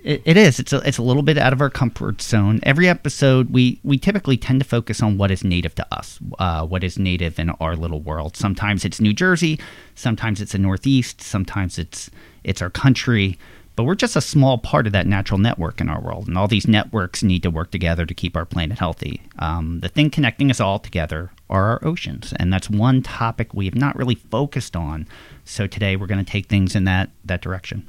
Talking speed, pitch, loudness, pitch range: 225 wpm, 105 Hz, -19 LUFS, 90-130 Hz